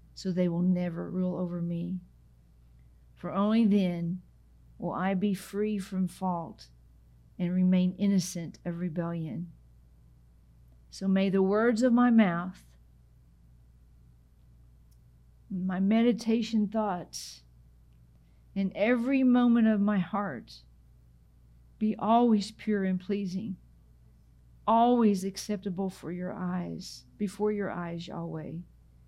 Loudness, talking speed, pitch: -29 LUFS, 105 wpm, 175 Hz